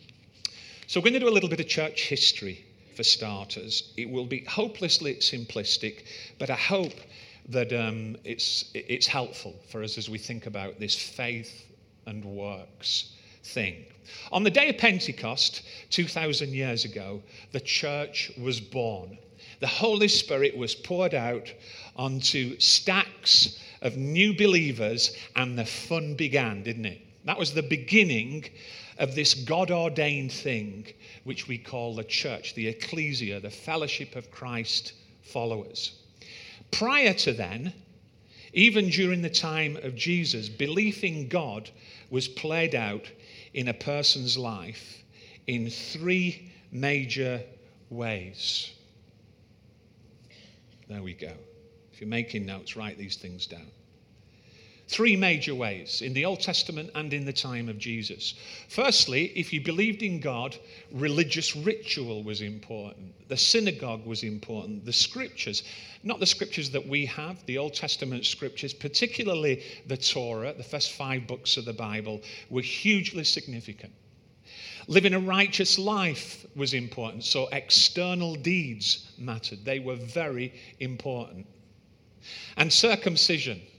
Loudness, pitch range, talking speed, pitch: -26 LUFS, 110-155 Hz, 135 wpm, 125 Hz